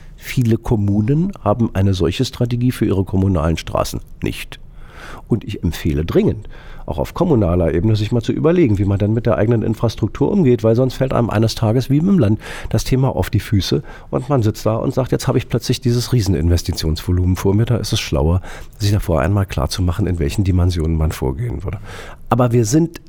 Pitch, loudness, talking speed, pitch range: 110 Hz, -17 LUFS, 195 wpm, 95-120 Hz